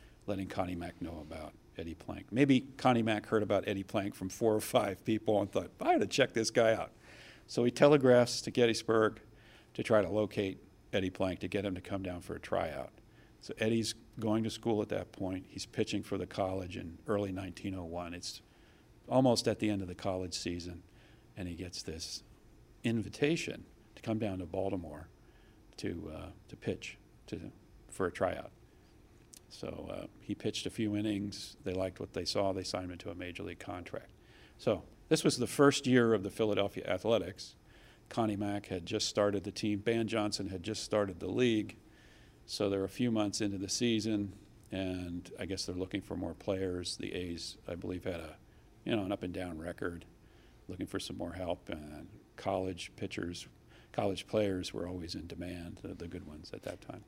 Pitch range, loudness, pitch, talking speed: 90-110 Hz, -35 LUFS, 100 Hz, 195 wpm